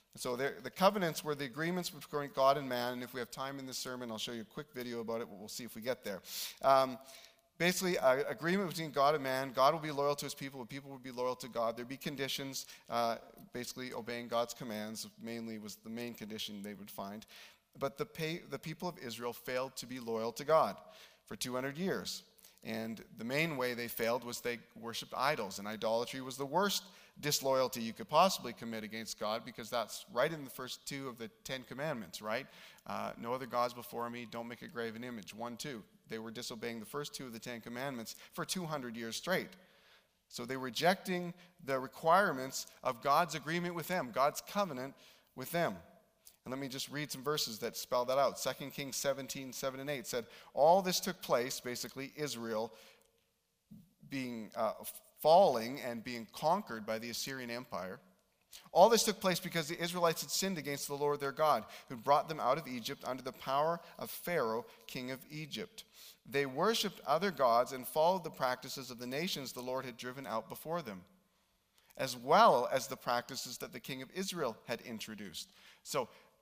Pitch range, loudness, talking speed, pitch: 120-155 Hz, -36 LUFS, 200 wpm, 130 Hz